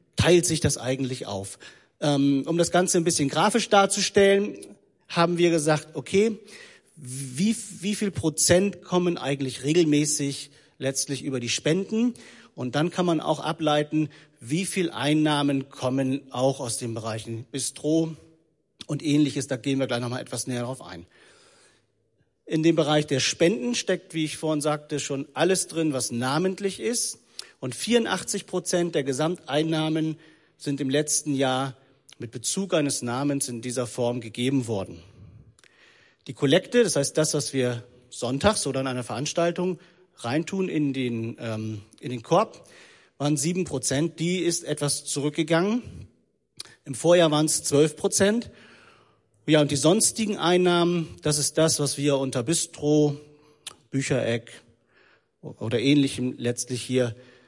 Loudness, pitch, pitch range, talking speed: -25 LUFS, 150 Hz, 135-175 Hz, 140 wpm